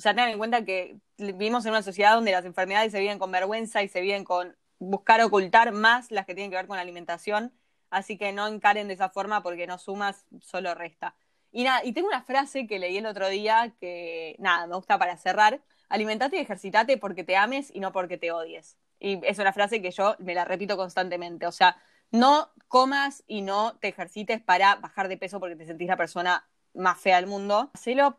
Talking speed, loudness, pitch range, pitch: 220 wpm, -26 LUFS, 185-220 Hz, 200 Hz